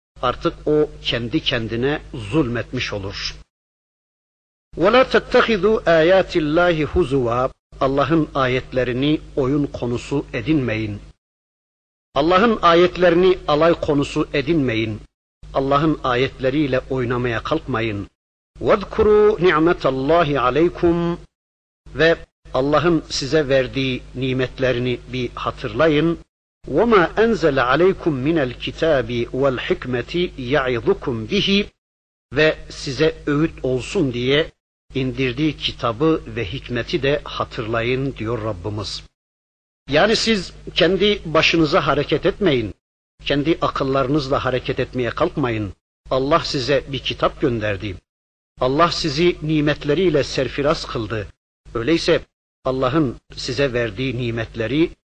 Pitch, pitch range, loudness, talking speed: 140 Hz, 120-160 Hz, -19 LUFS, 90 wpm